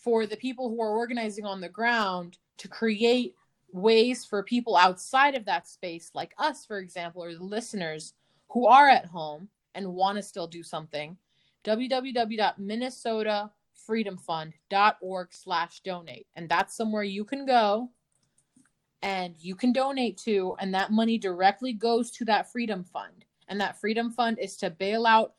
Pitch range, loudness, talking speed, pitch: 180-230 Hz, -27 LUFS, 155 wpm, 210 Hz